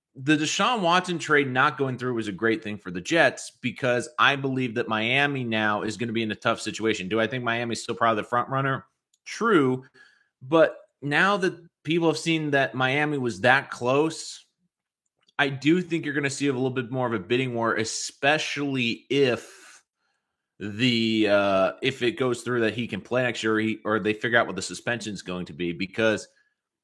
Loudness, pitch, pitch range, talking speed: -24 LUFS, 125 Hz, 110-145 Hz, 205 wpm